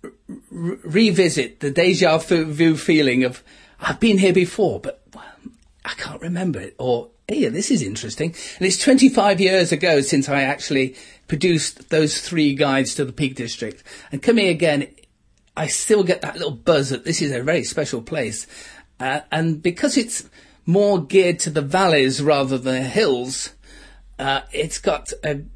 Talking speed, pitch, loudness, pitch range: 170 wpm, 160 Hz, -19 LUFS, 135-185 Hz